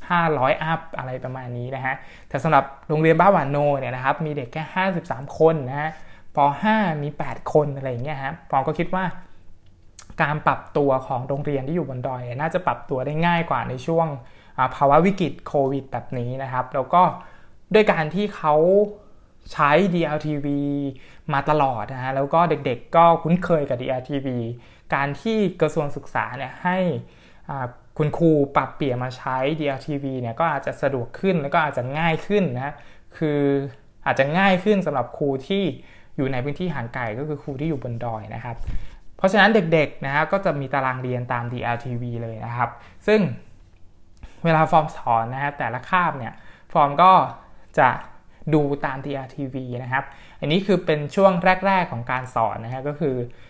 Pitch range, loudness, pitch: 130-165 Hz, -22 LUFS, 145 Hz